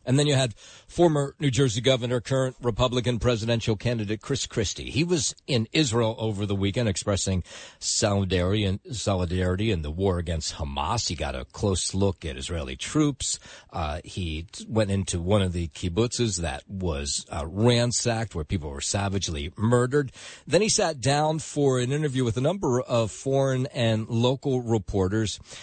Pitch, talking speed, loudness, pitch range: 110 Hz, 160 wpm, -26 LUFS, 90-125 Hz